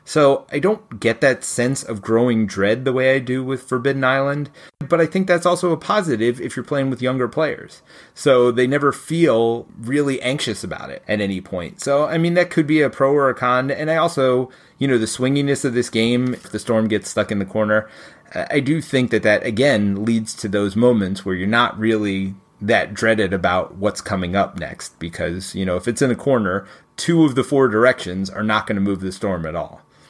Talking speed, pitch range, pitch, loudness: 225 wpm, 105-140 Hz, 125 Hz, -19 LUFS